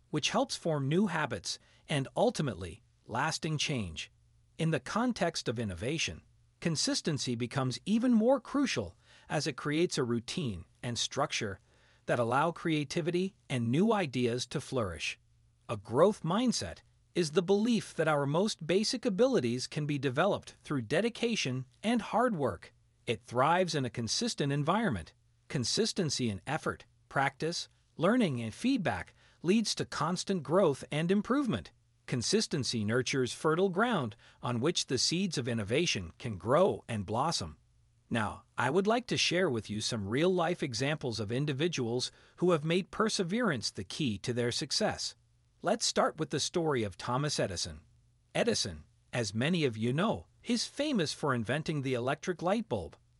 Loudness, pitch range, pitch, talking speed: -32 LUFS, 120-180 Hz, 140 Hz, 150 wpm